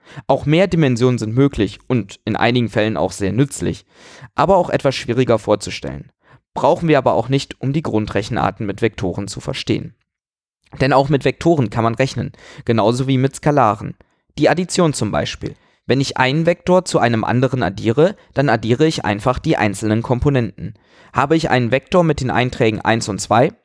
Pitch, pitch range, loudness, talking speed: 125 Hz, 110-145 Hz, -17 LUFS, 175 wpm